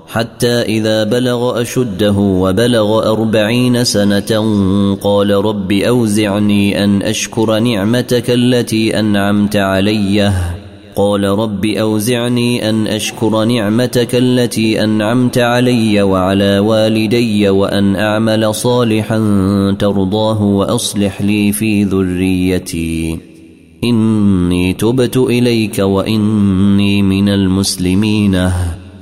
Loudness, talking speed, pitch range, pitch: -13 LUFS, 85 wpm, 100-110 Hz, 105 Hz